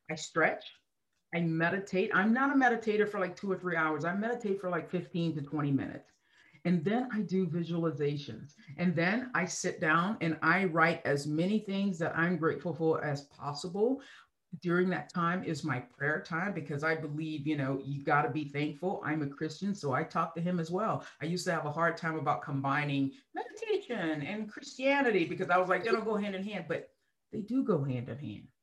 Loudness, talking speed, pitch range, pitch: -32 LUFS, 210 wpm, 155-195 Hz, 170 Hz